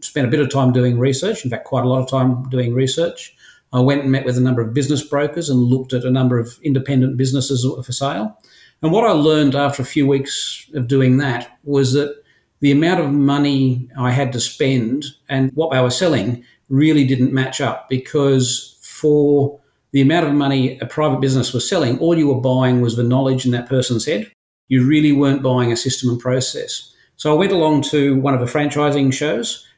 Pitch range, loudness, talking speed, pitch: 130-145 Hz, -17 LUFS, 215 wpm, 135 Hz